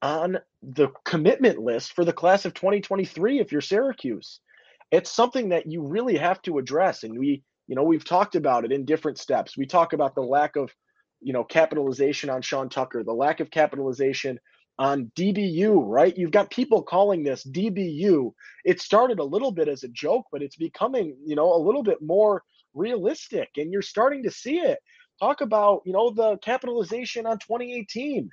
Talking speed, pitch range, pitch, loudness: 185 wpm, 145-225 Hz, 180 Hz, -24 LUFS